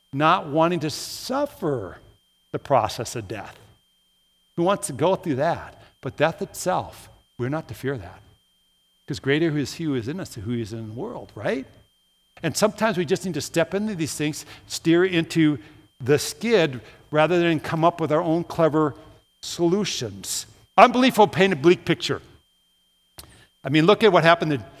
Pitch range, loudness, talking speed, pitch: 120-170 Hz, -22 LUFS, 180 wpm, 150 Hz